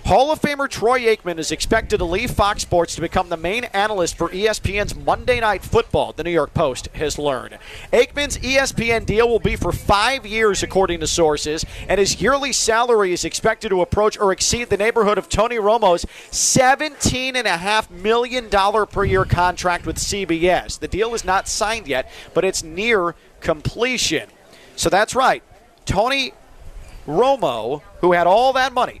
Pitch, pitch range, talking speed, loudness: 205 Hz, 175-235 Hz, 165 wpm, -19 LUFS